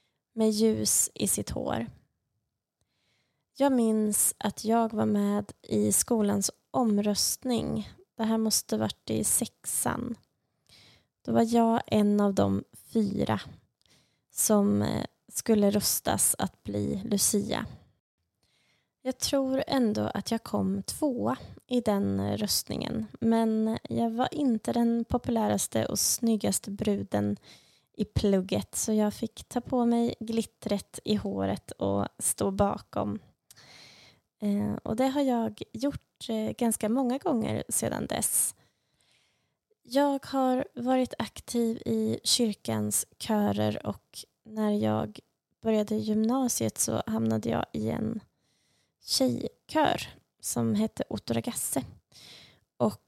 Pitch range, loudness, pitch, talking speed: 185-235 Hz, -28 LUFS, 215 Hz, 110 wpm